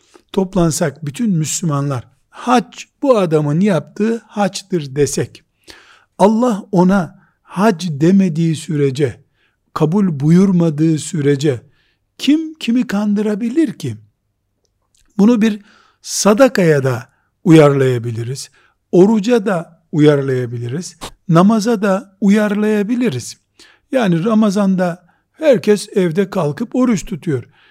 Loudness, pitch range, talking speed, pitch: -15 LUFS, 145-215 Hz, 85 wpm, 180 Hz